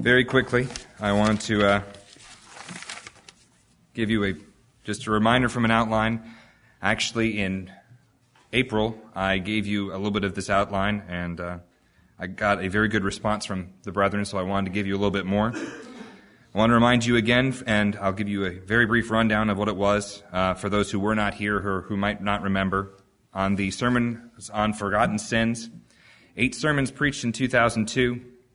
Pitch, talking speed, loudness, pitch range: 105 Hz, 185 wpm, -24 LUFS, 100-115 Hz